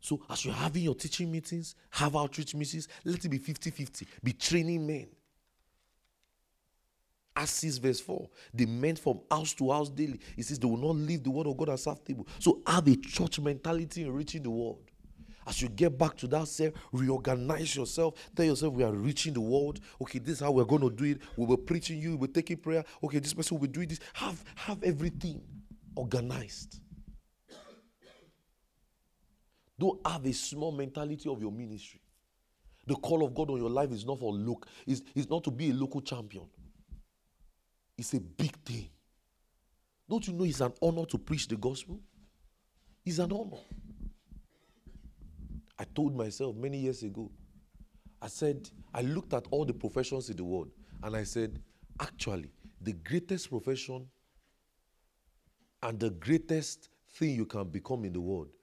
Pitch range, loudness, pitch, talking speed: 115-160 Hz, -33 LUFS, 140 Hz, 175 wpm